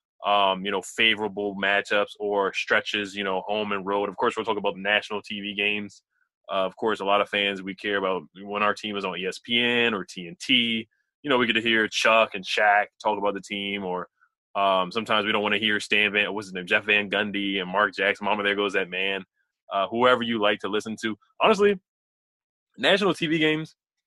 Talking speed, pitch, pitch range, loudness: 220 wpm, 105 Hz, 100-110 Hz, -24 LUFS